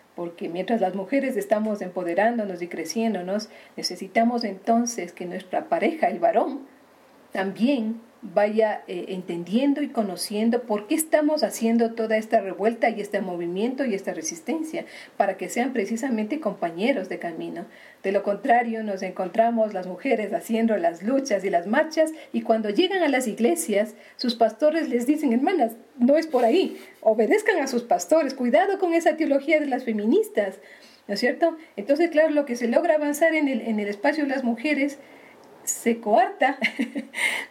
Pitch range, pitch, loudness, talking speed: 205-290 Hz, 230 Hz, -24 LUFS, 160 wpm